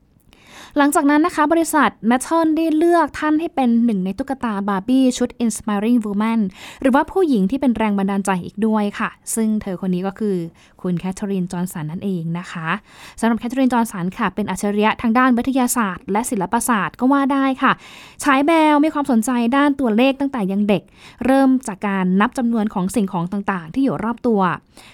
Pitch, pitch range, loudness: 230 Hz, 200-270 Hz, -18 LUFS